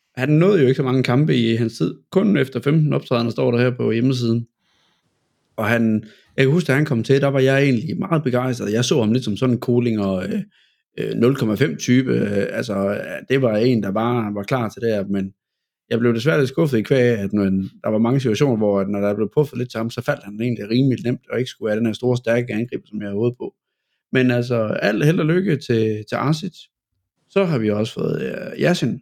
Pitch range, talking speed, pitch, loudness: 110-135 Hz, 230 wpm, 120 Hz, -20 LUFS